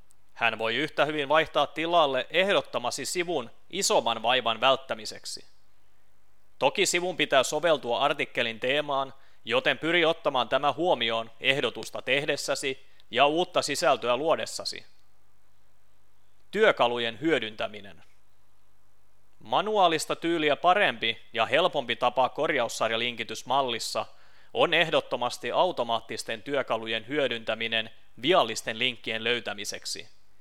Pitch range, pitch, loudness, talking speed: 100-140 Hz, 115 Hz, -26 LUFS, 90 wpm